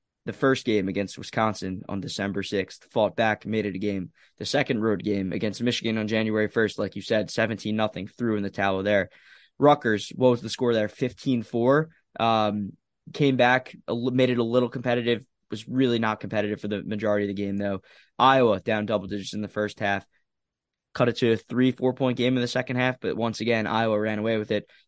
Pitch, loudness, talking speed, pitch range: 110 Hz, -25 LUFS, 210 wpm, 105-125 Hz